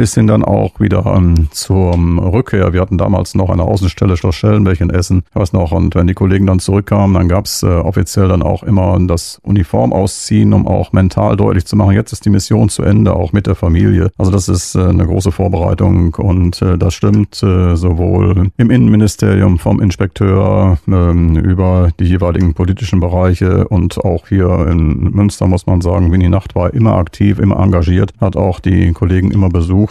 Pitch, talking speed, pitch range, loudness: 95 Hz, 190 wpm, 90-100 Hz, -12 LUFS